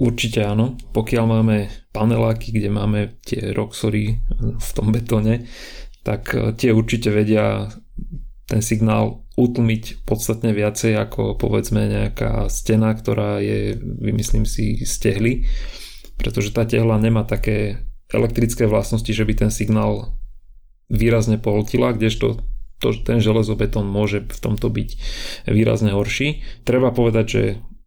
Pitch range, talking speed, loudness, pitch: 105-115 Hz, 120 wpm, -20 LUFS, 110 Hz